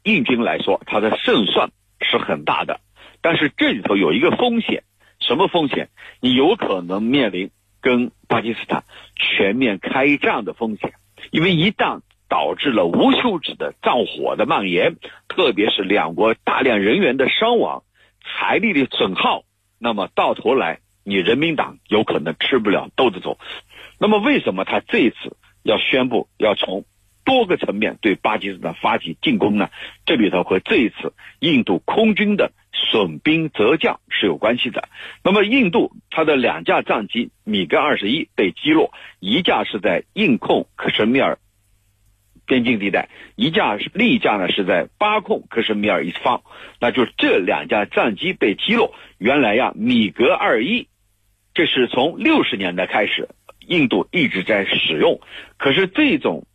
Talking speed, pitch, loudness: 245 characters per minute, 120 Hz, -18 LUFS